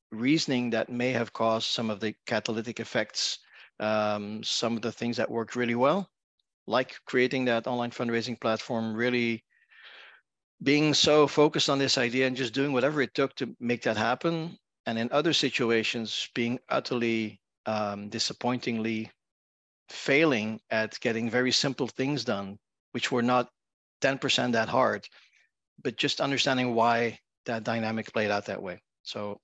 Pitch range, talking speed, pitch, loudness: 110-130 Hz, 155 wpm, 120 Hz, -28 LUFS